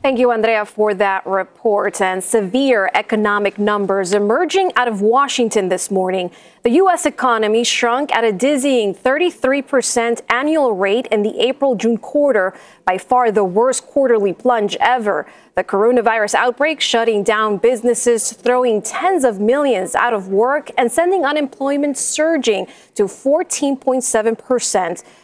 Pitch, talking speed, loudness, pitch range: 235 Hz, 135 wpm, -16 LUFS, 210-265 Hz